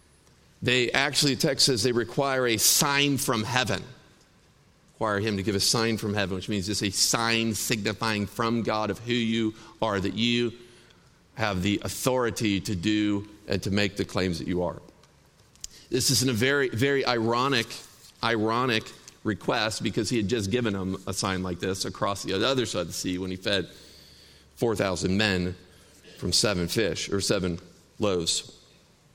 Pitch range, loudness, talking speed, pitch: 95-120 Hz, -26 LUFS, 175 wpm, 110 Hz